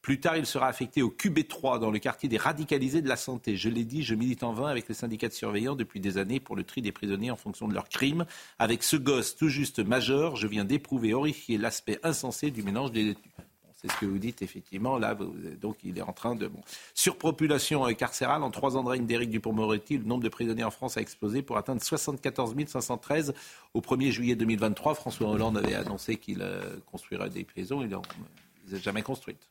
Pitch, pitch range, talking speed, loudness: 125 Hz, 110-140 Hz, 230 wpm, -30 LUFS